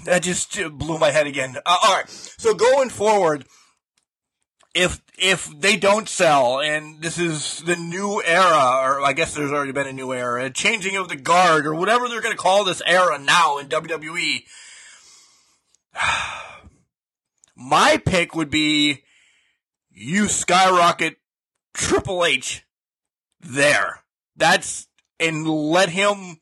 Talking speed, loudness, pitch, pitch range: 135 wpm, -19 LUFS, 165 Hz, 150-190 Hz